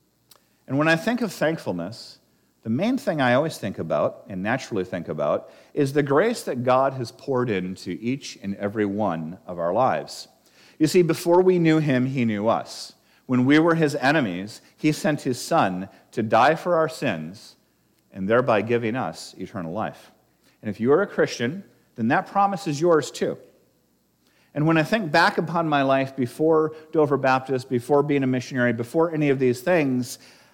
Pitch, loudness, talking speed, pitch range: 135 Hz, -23 LUFS, 185 wpm, 120-160 Hz